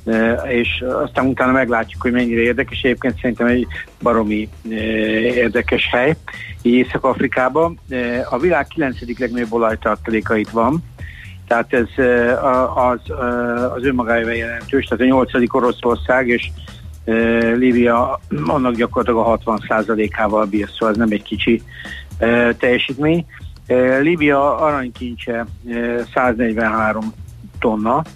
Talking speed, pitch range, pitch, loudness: 110 wpm, 110-125 Hz, 120 Hz, -17 LUFS